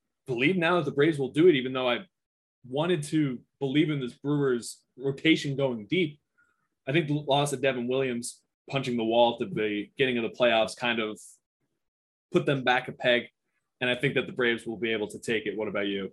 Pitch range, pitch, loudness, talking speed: 120-145 Hz, 130 Hz, -27 LUFS, 215 wpm